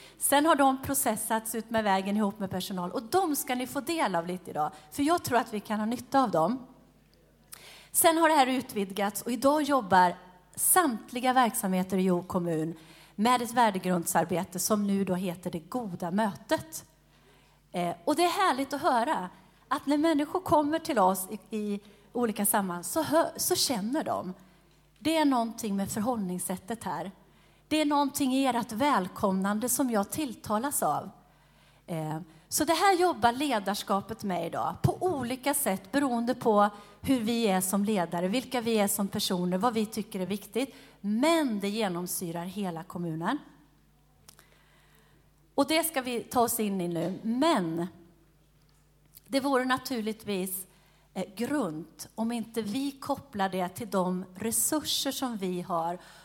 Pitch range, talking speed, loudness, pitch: 185-265 Hz, 155 wpm, -29 LUFS, 215 Hz